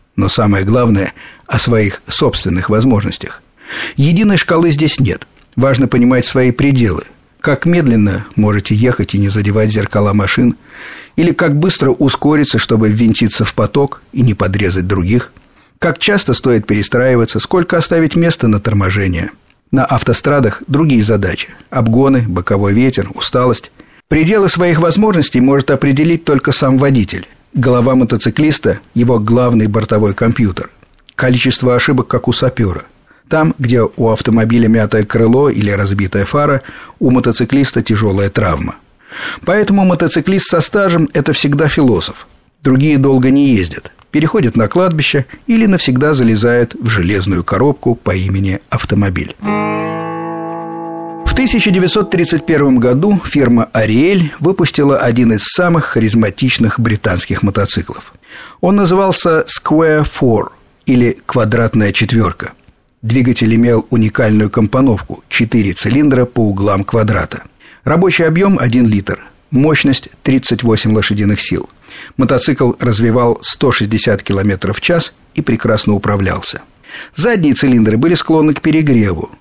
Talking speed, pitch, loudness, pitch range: 120 wpm, 125 Hz, -12 LUFS, 105-150 Hz